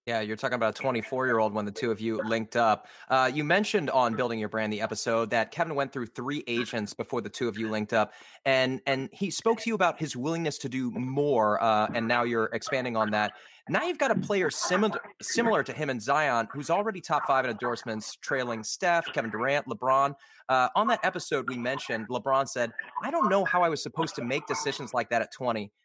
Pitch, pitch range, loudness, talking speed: 125 Hz, 115-145 Hz, -28 LUFS, 230 wpm